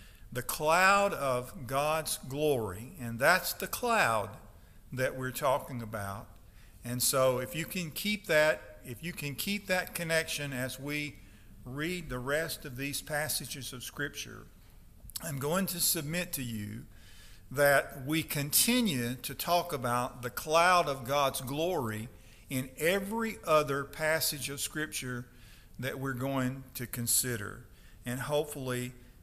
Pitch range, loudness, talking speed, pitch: 120-155 Hz, -31 LUFS, 135 wpm, 135 Hz